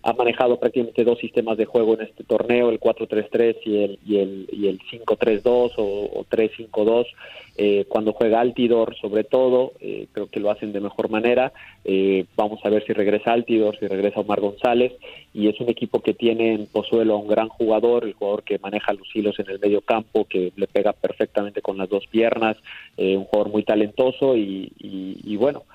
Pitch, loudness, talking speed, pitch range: 110 Hz, -21 LUFS, 200 wpm, 105-115 Hz